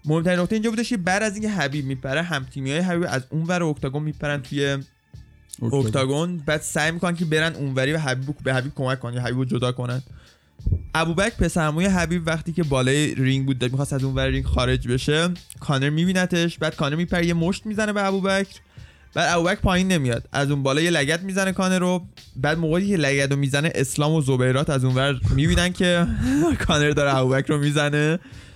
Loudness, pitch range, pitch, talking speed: -22 LUFS, 135-175 Hz, 150 Hz, 200 wpm